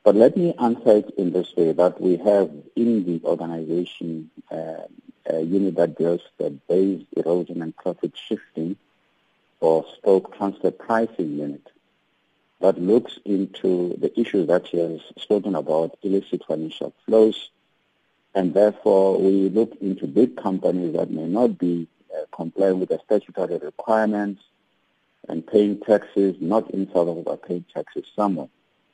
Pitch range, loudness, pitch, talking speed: 85-105 Hz, -22 LUFS, 95 Hz, 145 wpm